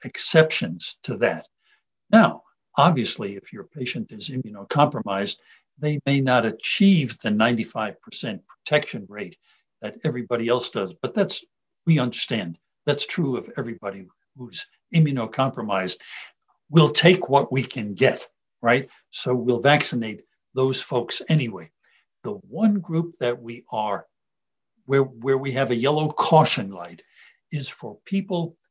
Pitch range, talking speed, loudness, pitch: 120-160 Hz, 130 wpm, -23 LUFS, 135 Hz